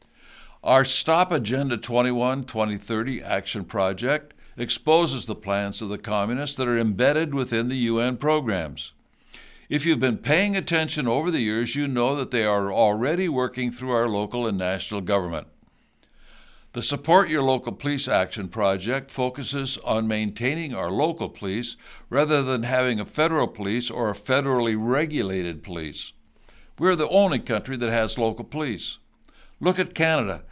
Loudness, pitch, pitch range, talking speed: -24 LUFS, 125 Hz, 110-145 Hz, 150 wpm